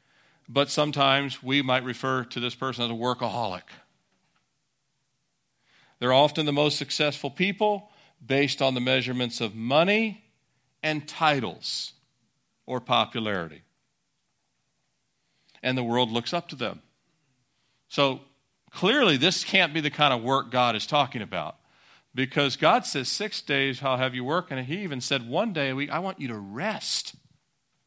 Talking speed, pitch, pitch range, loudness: 150 wpm, 135 Hz, 125-150 Hz, -25 LUFS